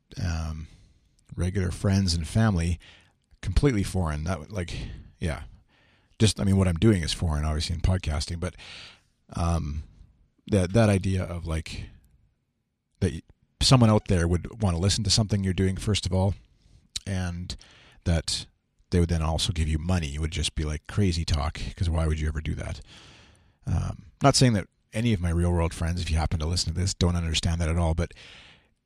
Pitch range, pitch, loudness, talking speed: 80-100 Hz, 90 Hz, -26 LUFS, 185 wpm